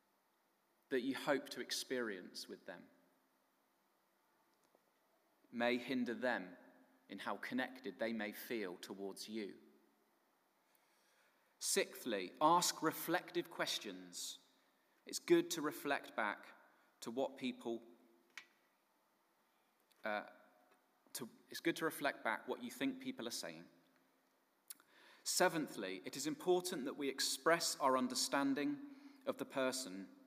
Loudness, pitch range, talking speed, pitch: -41 LUFS, 115-180 Hz, 110 wpm, 135 Hz